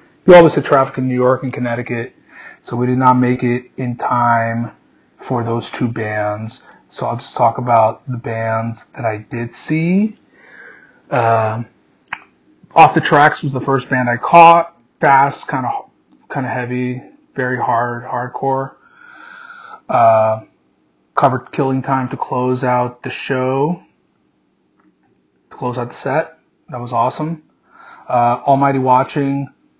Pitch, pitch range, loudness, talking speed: 125 Hz, 120-140 Hz, -15 LUFS, 145 wpm